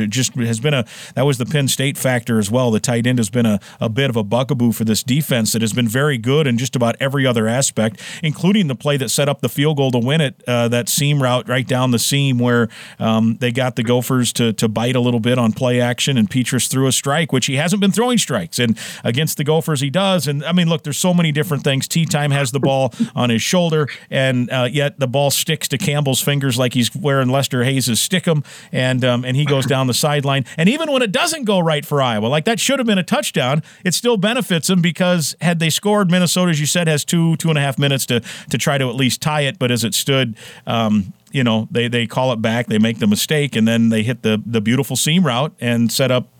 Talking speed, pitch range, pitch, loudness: 260 wpm, 120-155 Hz, 135 Hz, -17 LUFS